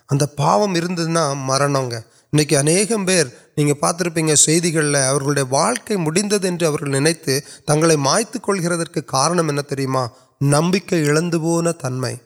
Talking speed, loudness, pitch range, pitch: 75 wpm, -18 LUFS, 140-170 Hz, 155 Hz